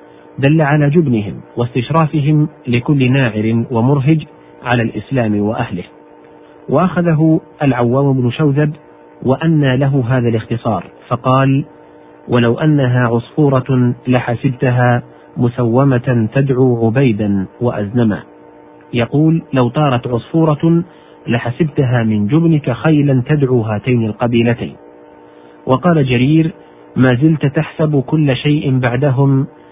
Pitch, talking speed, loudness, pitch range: 125 Hz, 95 wpm, -14 LUFS, 115-145 Hz